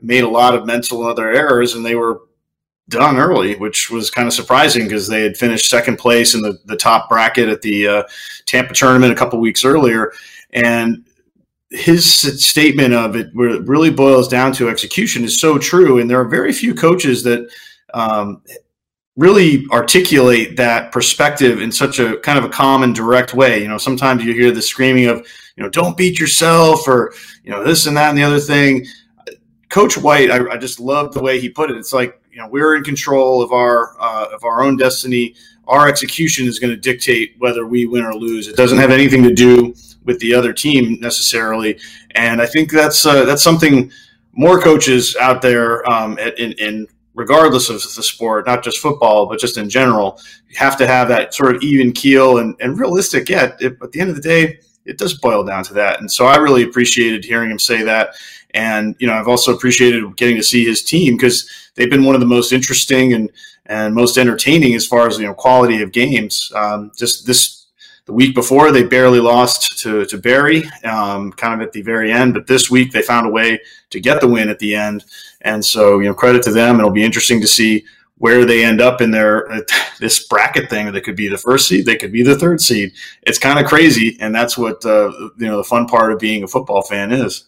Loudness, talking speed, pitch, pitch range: -12 LUFS, 220 wpm, 120 Hz, 115-135 Hz